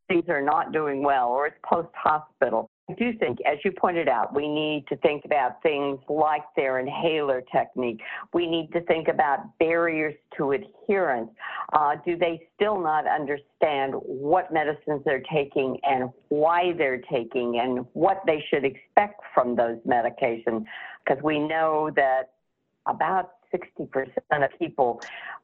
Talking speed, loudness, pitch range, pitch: 150 wpm, -25 LUFS, 135-170 Hz, 155 Hz